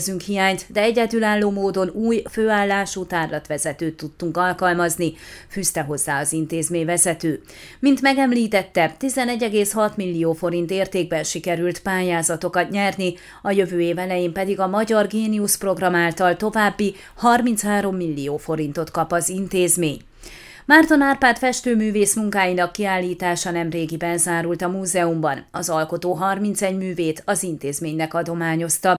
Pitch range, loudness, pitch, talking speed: 170-205 Hz, -20 LUFS, 180 Hz, 115 wpm